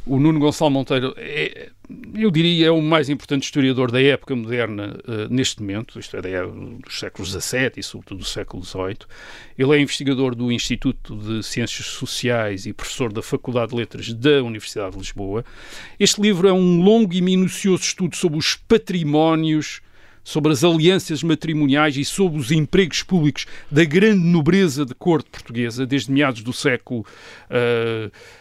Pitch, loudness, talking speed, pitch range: 135 Hz, -19 LUFS, 165 wpm, 115-160 Hz